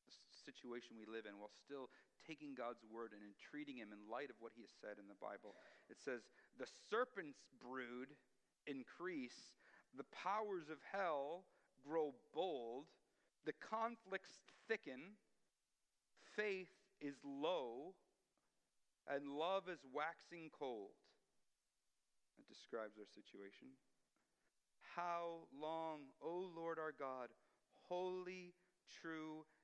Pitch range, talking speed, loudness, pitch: 125-180 Hz, 115 wpm, -50 LUFS, 150 Hz